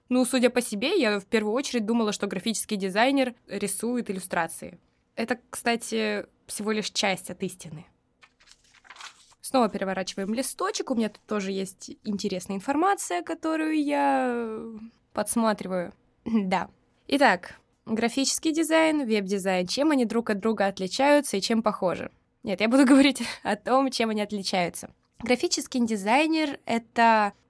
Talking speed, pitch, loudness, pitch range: 130 wpm, 225 Hz, -26 LUFS, 200-265 Hz